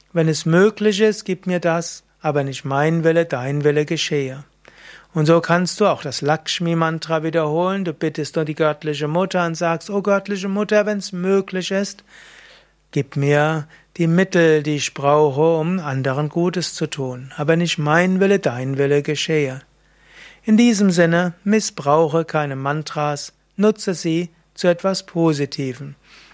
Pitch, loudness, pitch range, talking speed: 165 Hz, -19 LUFS, 150-185 Hz, 155 wpm